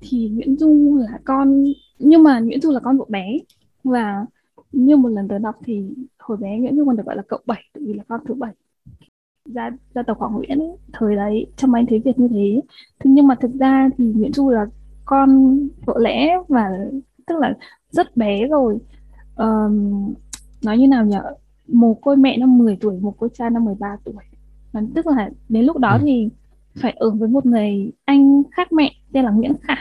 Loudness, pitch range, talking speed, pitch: -17 LUFS, 220-275 Hz, 205 wpm, 250 Hz